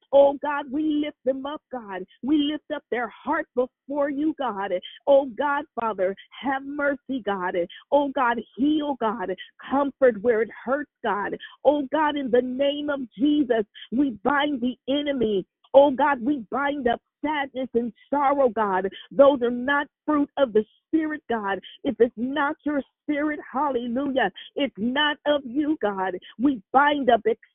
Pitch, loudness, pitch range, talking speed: 275 Hz, -24 LUFS, 235-290 Hz, 155 wpm